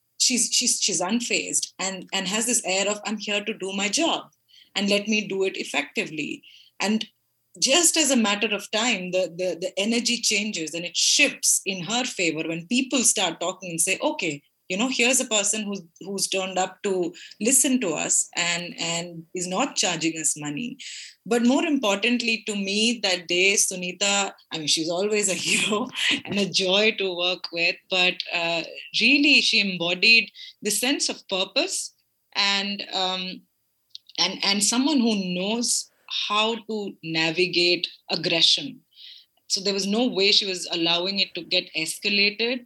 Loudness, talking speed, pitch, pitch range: -22 LUFS, 165 wpm, 200 Hz, 180-230 Hz